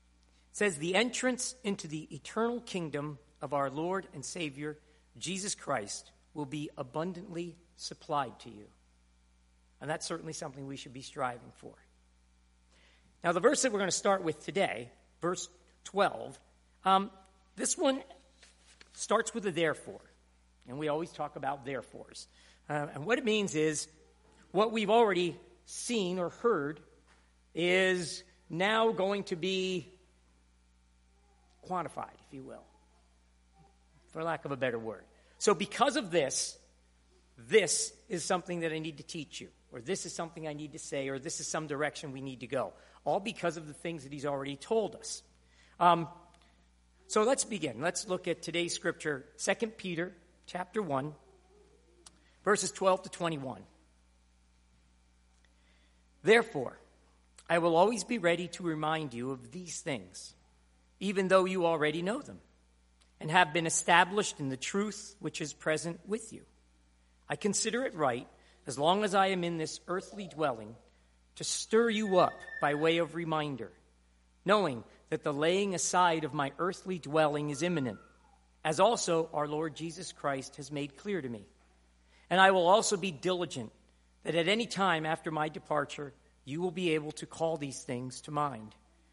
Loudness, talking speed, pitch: -32 LUFS, 160 wpm, 155 Hz